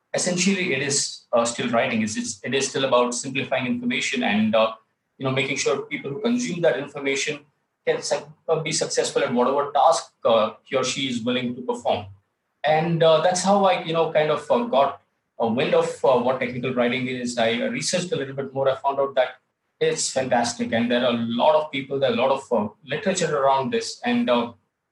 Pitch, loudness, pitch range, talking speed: 140 Hz, -22 LUFS, 125-190 Hz, 215 wpm